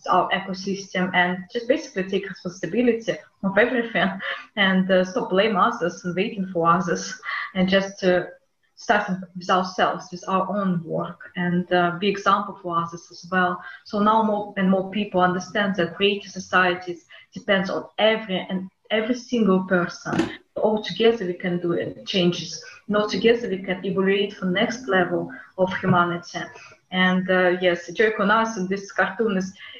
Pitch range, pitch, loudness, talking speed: 180-205 Hz, 190 Hz, -23 LUFS, 165 wpm